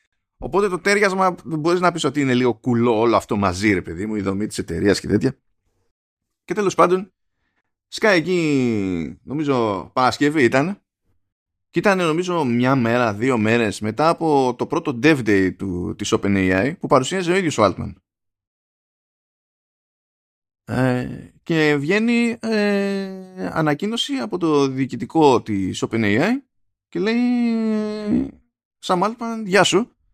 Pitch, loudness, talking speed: 135 Hz, -19 LUFS, 135 wpm